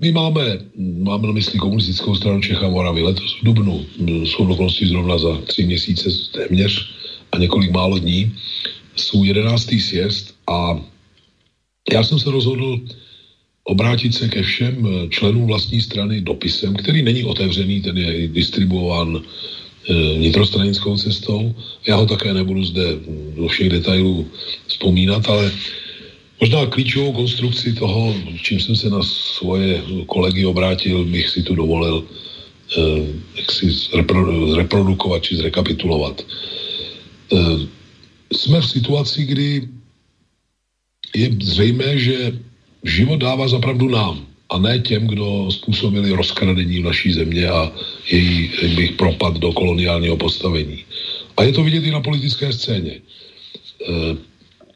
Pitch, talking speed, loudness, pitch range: 95 Hz, 125 wpm, -17 LUFS, 85-110 Hz